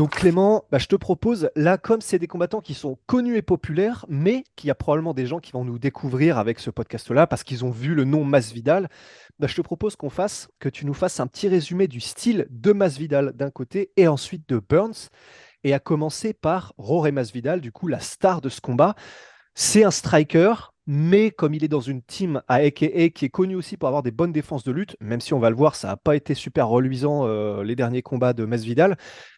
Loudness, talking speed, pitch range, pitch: -22 LUFS, 235 wpm, 130-185 Hz, 150 Hz